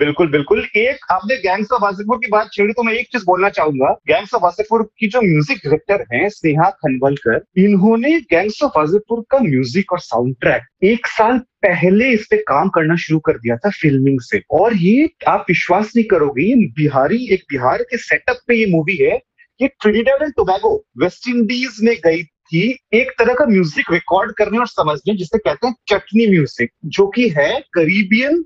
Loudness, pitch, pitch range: -15 LUFS, 205 Hz, 165-235 Hz